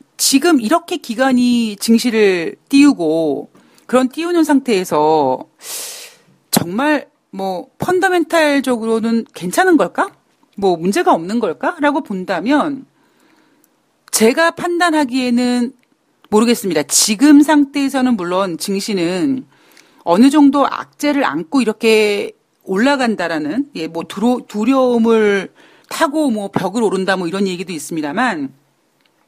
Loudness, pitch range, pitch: -15 LUFS, 200-300 Hz, 255 Hz